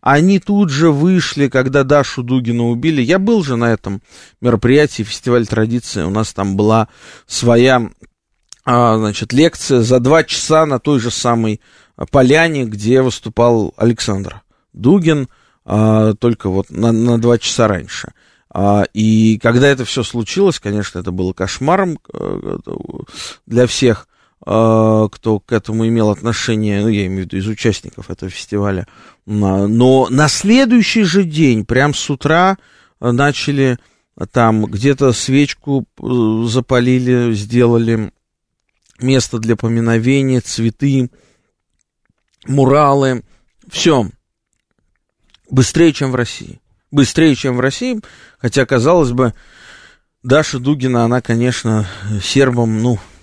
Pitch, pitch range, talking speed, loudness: 120 Hz, 110-140 Hz, 115 wpm, -14 LUFS